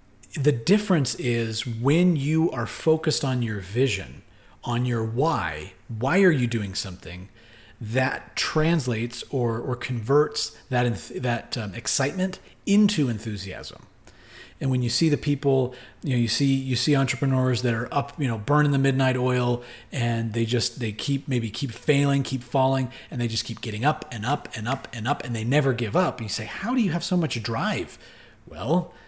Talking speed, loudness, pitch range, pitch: 185 wpm, -25 LUFS, 115-145 Hz, 125 Hz